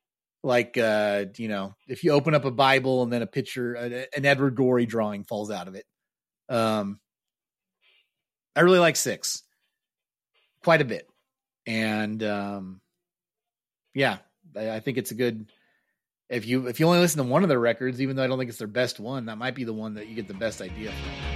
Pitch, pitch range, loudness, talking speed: 120 Hz, 110-135 Hz, -25 LUFS, 195 wpm